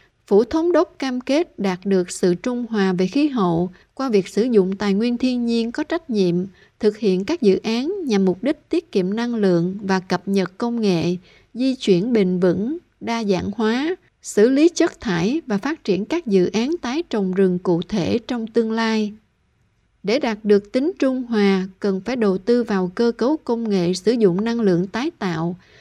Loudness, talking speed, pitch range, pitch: -20 LUFS, 200 wpm, 190-250 Hz, 215 Hz